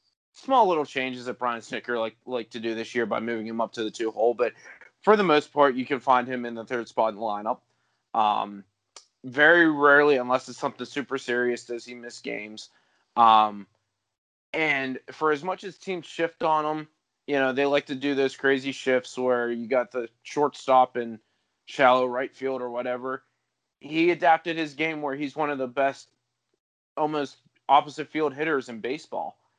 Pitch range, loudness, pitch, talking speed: 120-145 Hz, -25 LUFS, 130 Hz, 190 wpm